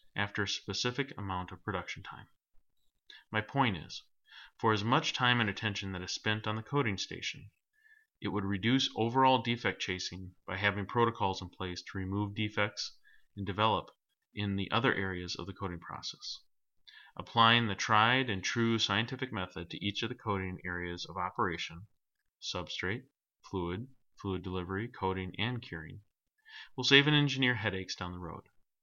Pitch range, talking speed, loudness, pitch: 95-120 Hz, 160 wpm, -33 LUFS, 105 Hz